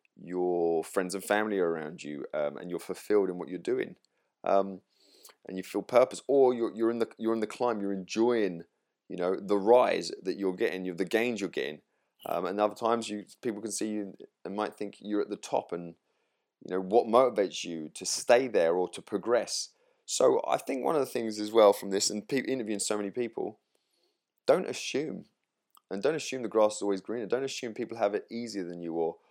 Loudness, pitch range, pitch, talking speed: -30 LUFS, 95-115 Hz, 105 Hz, 220 wpm